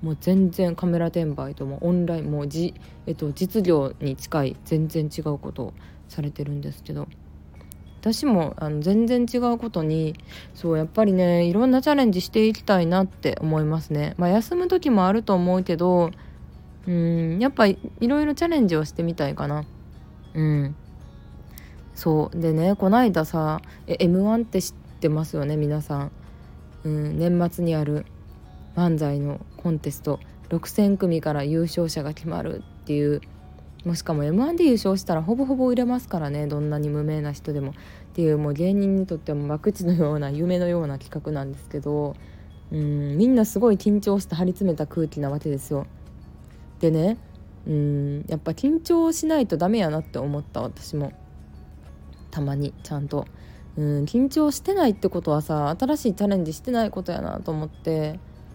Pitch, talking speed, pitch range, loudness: 160 Hz, 330 characters per minute, 145-190 Hz, -24 LUFS